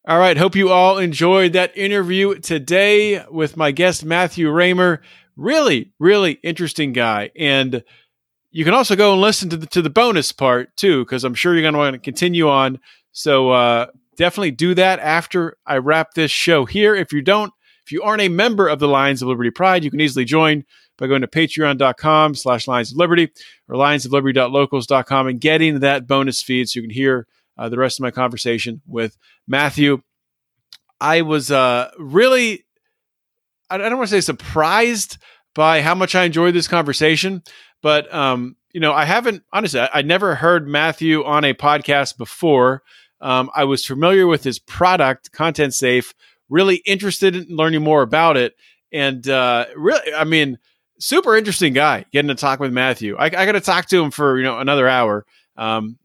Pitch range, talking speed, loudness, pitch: 130-180 Hz, 185 wpm, -16 LUFS, 155 Hz